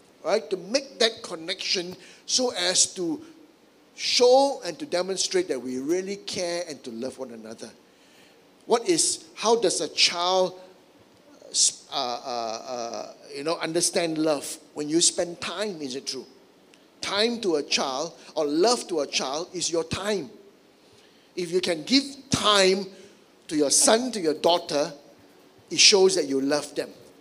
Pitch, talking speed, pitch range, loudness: 185 Hz, 155 wpm, 160-225 Hz, -24 LUFS